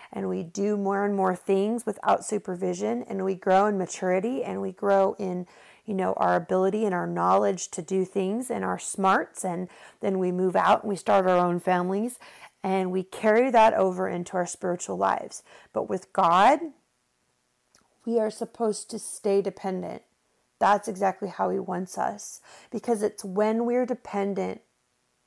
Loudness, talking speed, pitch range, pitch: -26 LUFS, 170 wpm, 185-210 Hz, 195 Hz